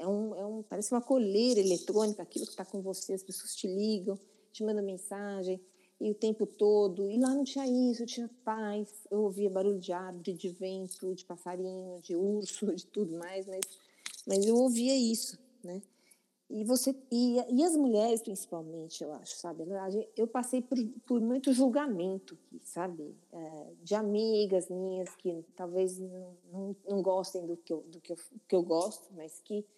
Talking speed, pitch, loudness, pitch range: 160 wpm, 200 Hz, -33 LUFS, 185-220 Hz